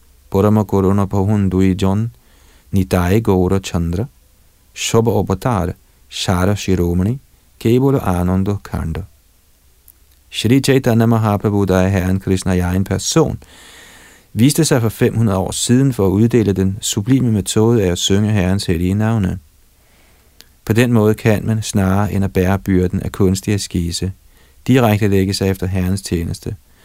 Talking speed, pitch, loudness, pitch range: 130 wpm, 95 Hz, -16 LUFS, 90-110 Hz